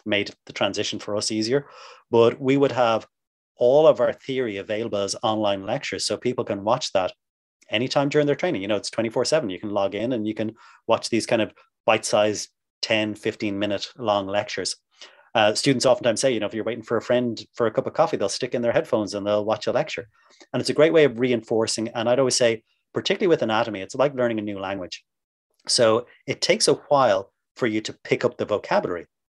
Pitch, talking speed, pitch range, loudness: 110 Hz, 225 wpm, 105-125 Hz, -23 LUFS